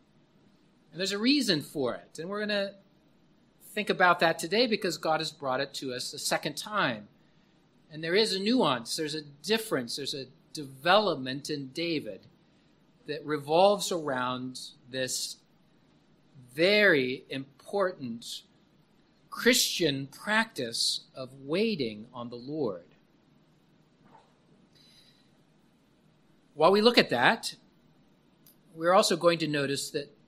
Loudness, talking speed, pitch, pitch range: -28 LUFS, 120 wpm, 160 Hz, 140-200 Hz